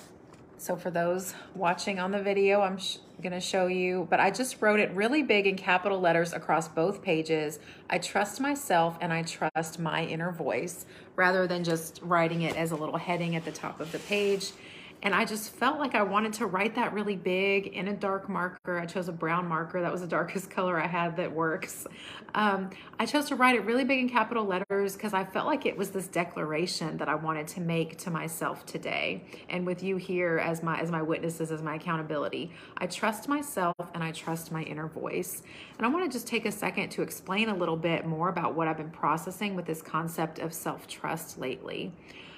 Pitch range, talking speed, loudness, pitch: 165-200 Hz, 215 wpm, -30 LUFS, 180 Hz